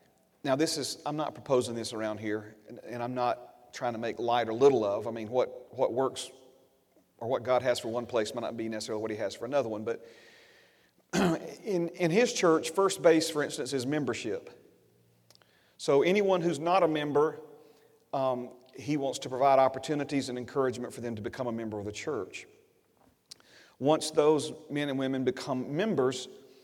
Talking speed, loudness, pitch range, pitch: 185 wpm, -30 LUFS, 120-155 Hz, 135 Hz